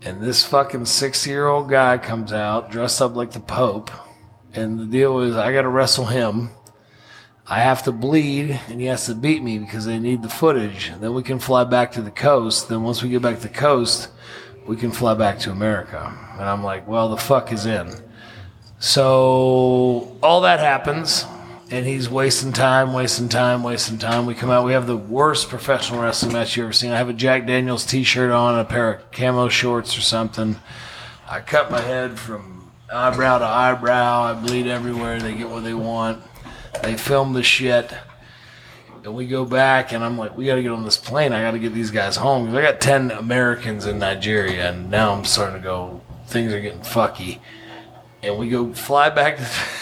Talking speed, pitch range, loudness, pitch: 205 wpm, 115-130 Hz, -19 LUFS, 120 Hz